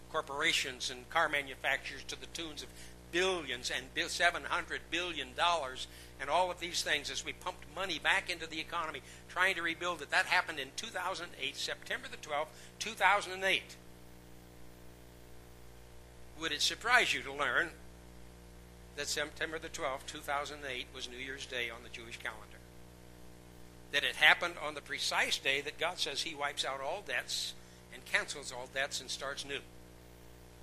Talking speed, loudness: 155 wpm, -34 LUFS